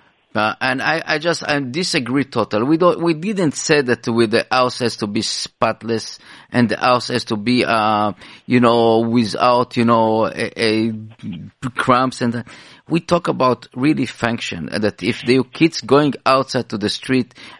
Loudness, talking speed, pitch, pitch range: -17 LUFS, 175 wpm, 125 Hz, 115-140 Hz